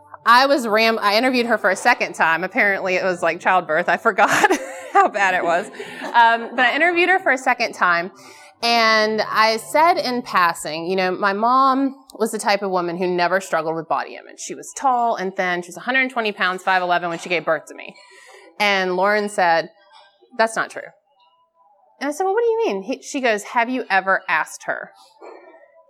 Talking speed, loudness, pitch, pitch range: 200 wpm, -18 LUFS, 215 Hz, 185-255 Hz